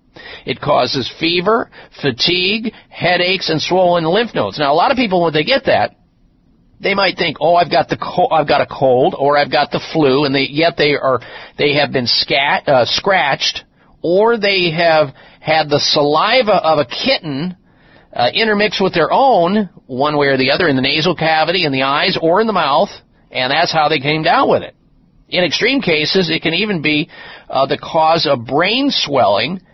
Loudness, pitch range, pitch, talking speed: -14 LUFS, 145-185 Hz, 160 Hz, 195 wpm